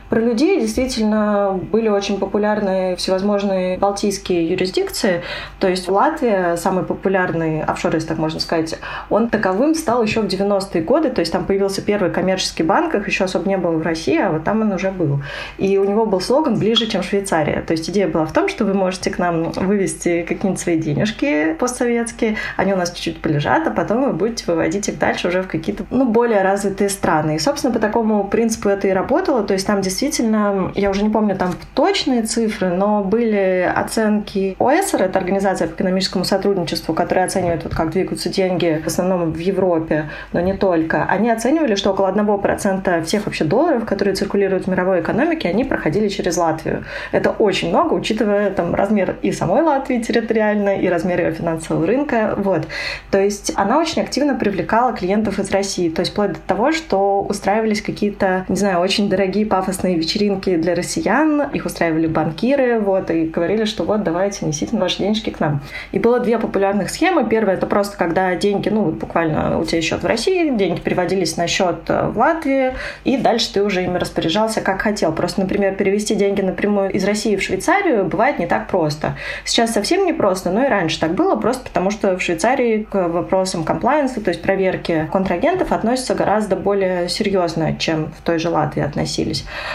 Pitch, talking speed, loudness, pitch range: 195 Hz, 185 wpm, -18 LUFS, 180-215 Hz